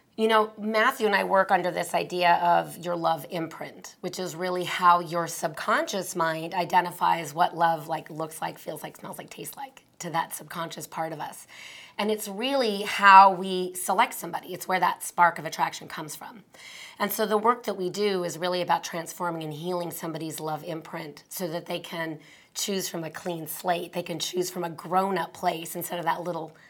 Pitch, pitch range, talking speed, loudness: 175 Hz, 165-190 Hz, 200 wpm, -26 LUFS